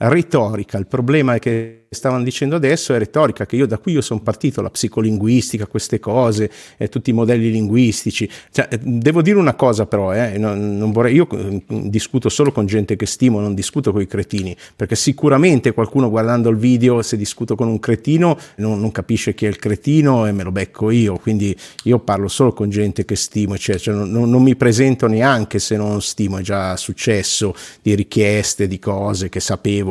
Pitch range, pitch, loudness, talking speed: 105-125 Hz, 110 Hz, -17 LUFS, 195 wpm